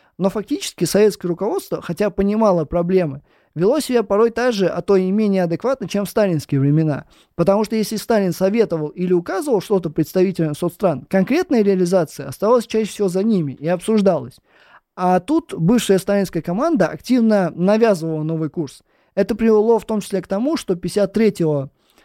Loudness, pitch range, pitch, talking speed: -18 LUFS, 175-215 Hz, 195 Hz, 160 wpm